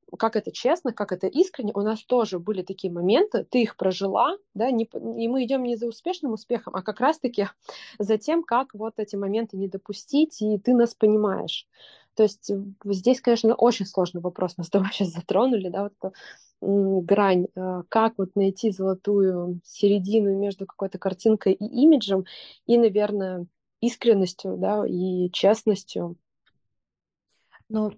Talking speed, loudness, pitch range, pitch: 155 wpm, -24 LUFS, 195-230 Hz, 210 Hz